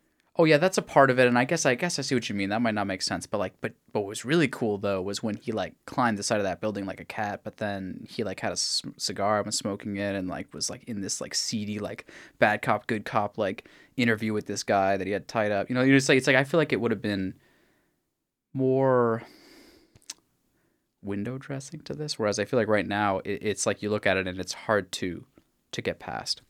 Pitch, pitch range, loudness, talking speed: 105 Hz, 100-130 Hz, -27 LUFS, 270 wpm